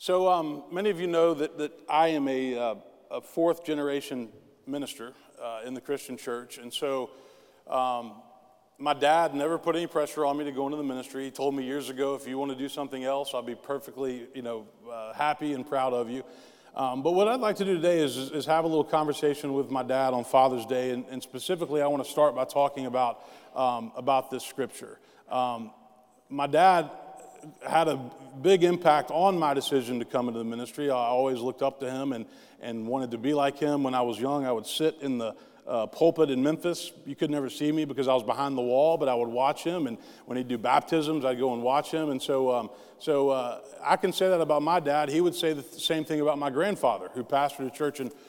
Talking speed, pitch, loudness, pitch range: 235 wpm, 140 Hz, -28 LUFS, 130-155 Hz